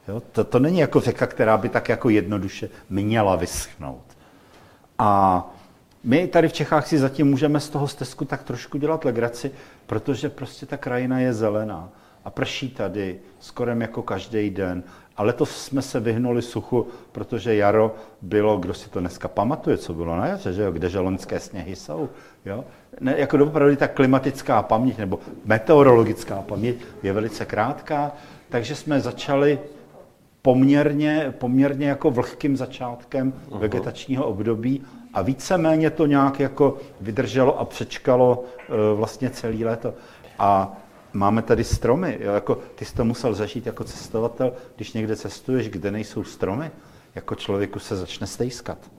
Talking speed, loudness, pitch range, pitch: 150 wpm, -22 LUFS, 105-140 Hz, 120 Hz